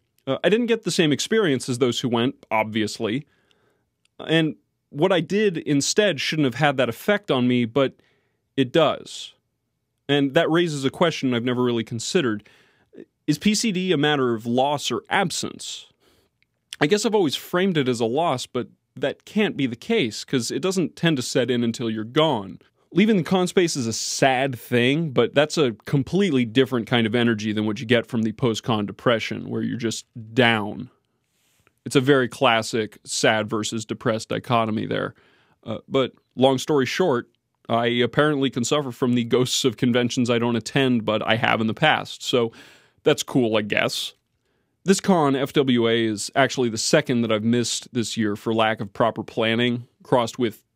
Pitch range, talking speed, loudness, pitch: 115-150 Hz, 180 wpm, -22 LUFS, 125 Hz